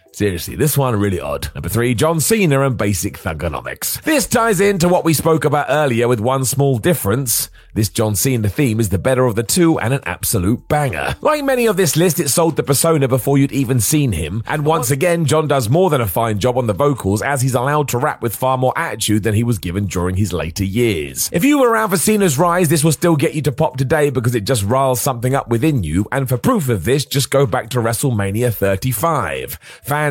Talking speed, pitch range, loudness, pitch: 235 wpm, 115-155 Hz, -16 LUFS, 135 Hz